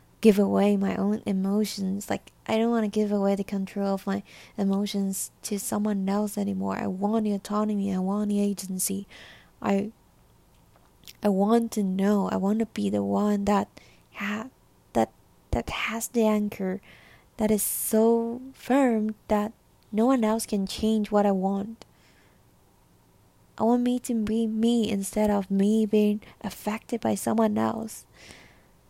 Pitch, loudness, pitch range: 205 Hz, -26 LUFS, 195-220 Hz